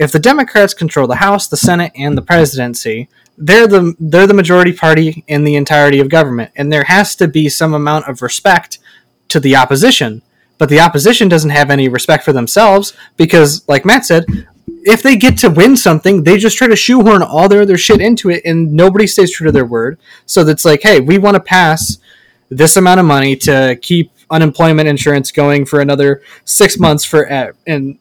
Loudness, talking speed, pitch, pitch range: -9 LUFS, 205 wpm, 160 Hz, 145-190 Hz